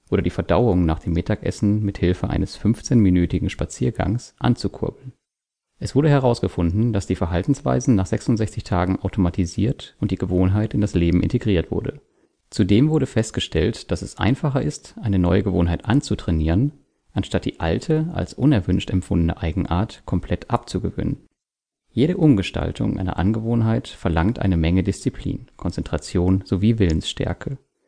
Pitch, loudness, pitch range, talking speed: 100 Hz, -21 LUFS, 90-120 Hz, 130 wpm